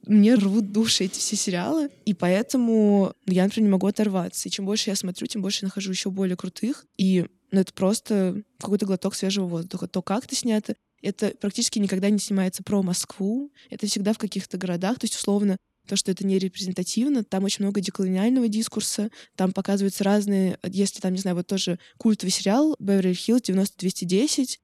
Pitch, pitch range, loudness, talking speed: 200 Hz, 190-215 Hz, -24 LUFS, 190 wpm